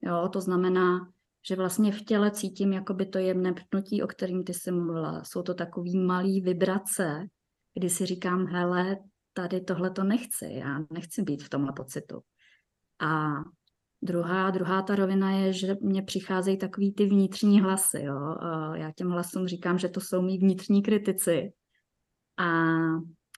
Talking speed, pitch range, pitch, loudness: 160 wpm, 175-195 Hz, 185 Hz, -28 LUFS